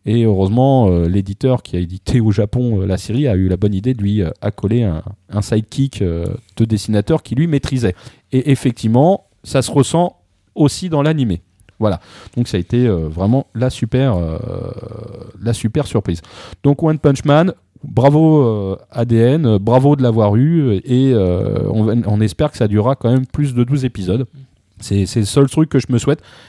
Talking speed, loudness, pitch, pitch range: 175 wpm, -16 LUFS, 120 Hz, 100-135 Hz